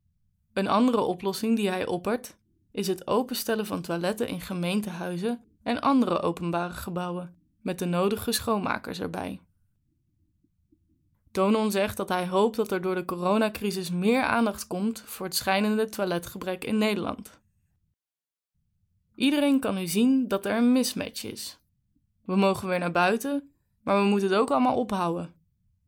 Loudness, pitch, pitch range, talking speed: -27 LUFS, 195 Hz, 175-220 Hz, 145 wpm